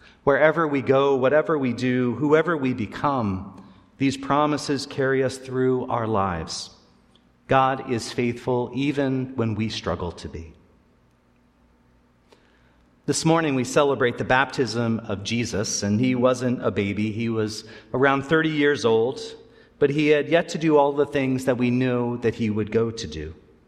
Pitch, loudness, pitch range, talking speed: 125 Hz, -23 LUFS, 100-140 Hz, 155 wpm